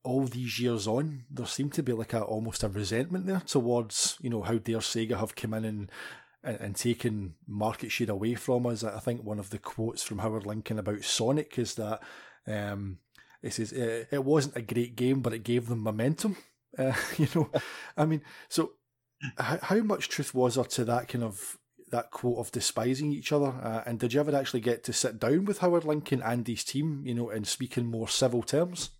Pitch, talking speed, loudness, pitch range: 120 Hz, 215 wpm, -31 LUFS, 115-140 Hz